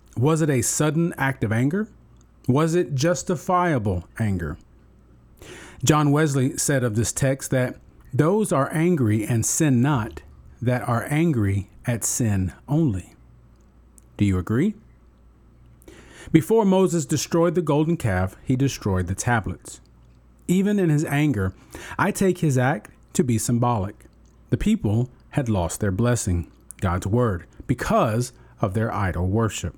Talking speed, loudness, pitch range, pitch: 135 wpm, -22 LUFS, 95-150 Hz, 120 Hz